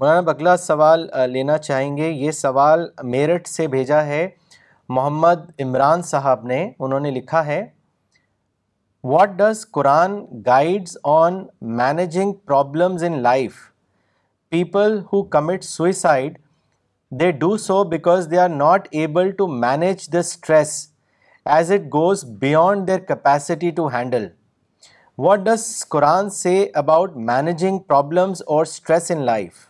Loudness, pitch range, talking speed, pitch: -18 LUFS, 140-180 Hz, 130 wpm, 160 Hz